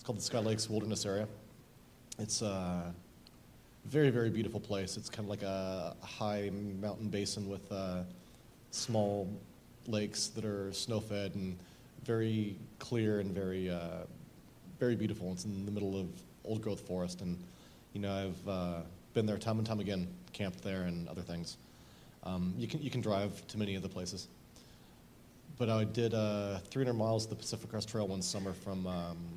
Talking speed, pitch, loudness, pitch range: 175 wpm, 100 Hz, -38 LUFS, 90-110 Hz